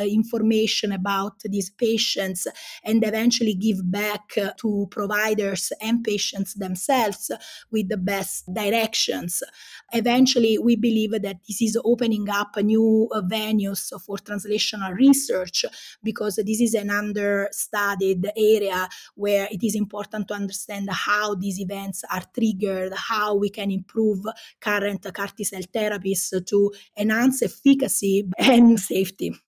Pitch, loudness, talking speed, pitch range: 210 Hz, -23 LUFS, 120 wpm, 200-220 Hz